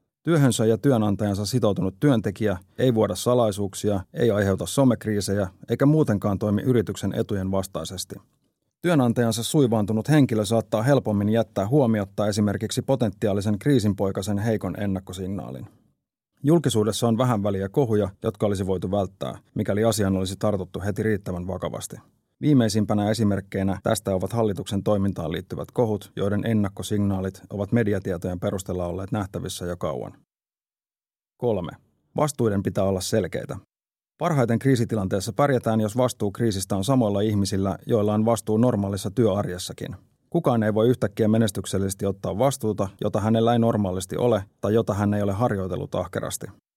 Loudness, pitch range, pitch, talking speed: -24 LUFS, 100-115 Hz, 105 Hz, 130 wpm